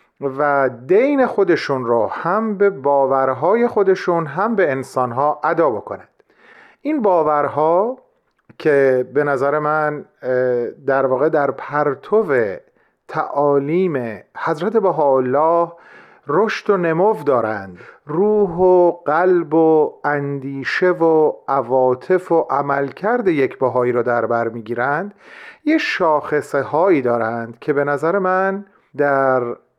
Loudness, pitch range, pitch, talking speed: -17 LUFS, 135-190 Hz, 150 Hz, 110 wpm